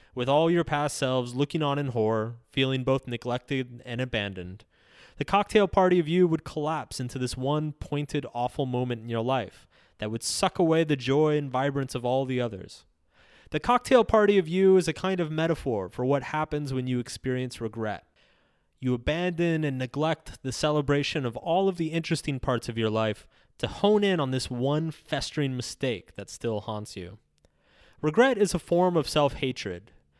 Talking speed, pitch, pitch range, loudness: 185 wpm, 135 Hz, 120-160 Hz, -27 LUFS